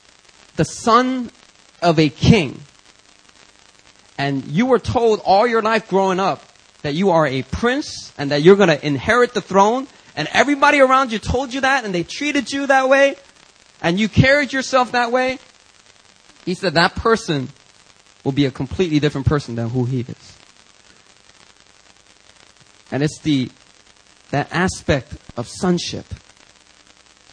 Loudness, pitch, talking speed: -17 LUFS, 150 Hz, 145 wpm